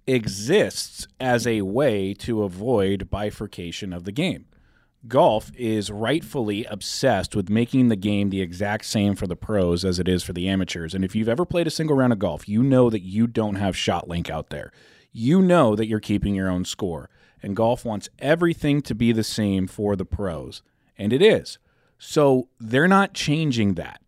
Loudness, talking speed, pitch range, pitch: -22 LUFS, 190 wpm, 95-120 Hz, 105 Hz